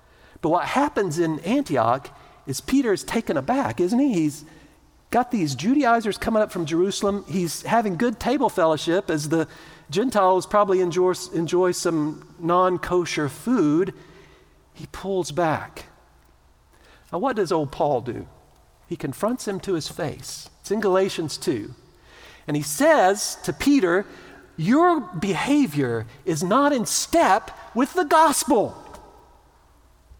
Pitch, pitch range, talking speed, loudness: 185 Hz, 160-240 Hz, 135 wpm, -22 LUFS